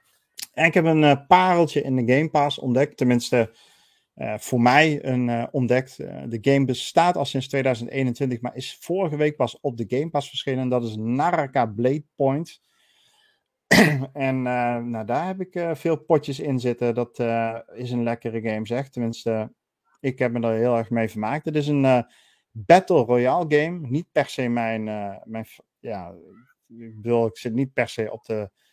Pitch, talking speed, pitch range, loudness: 130 Hz, 190 wpm, 120-145 Hz, -22 LUFS